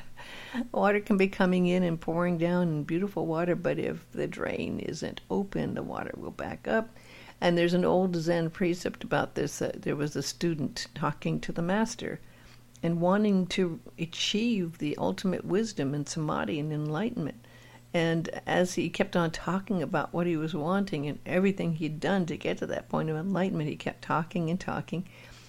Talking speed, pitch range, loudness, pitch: 185 wpm, 155-185 Hz, -30 LUFS, 170 Hz